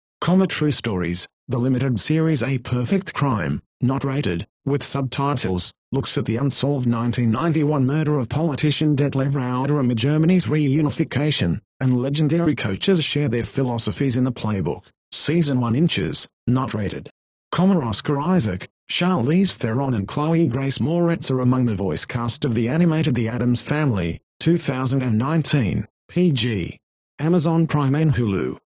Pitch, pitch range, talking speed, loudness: 135 Hz, 120-155 Hz, 140 wpm, -21 LUFS